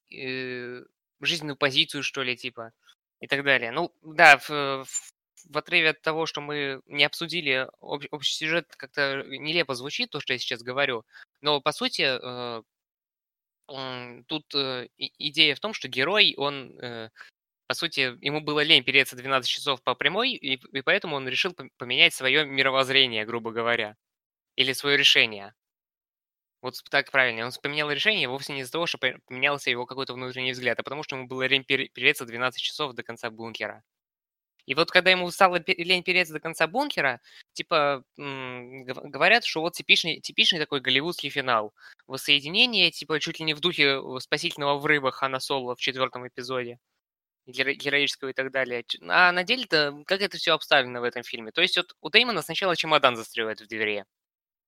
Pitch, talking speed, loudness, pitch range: 140 Hz, 165 wpm, -24 LUFS, 130-155 Hz